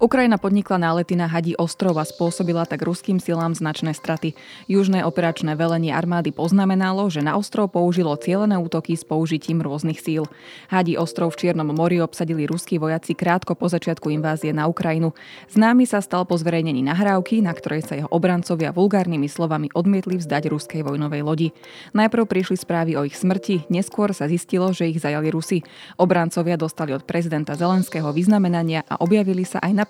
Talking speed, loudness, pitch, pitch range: 170 wpm, -21 LUFS, 170 Hz, 160-185 Hz